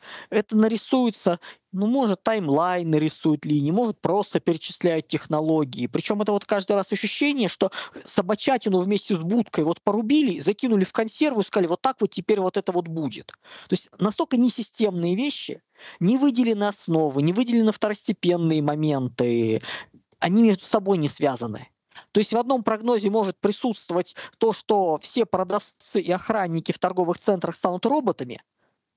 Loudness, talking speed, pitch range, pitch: -23 LUFS, 150 wpm, 170-225 Hz, 200 Hz